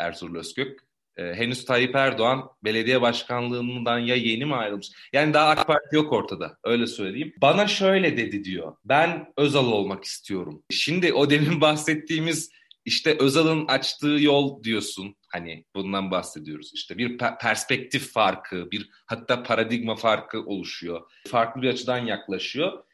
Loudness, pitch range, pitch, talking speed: -24 LUFS, 105-145 Hz, 120 Hz, 140 wpm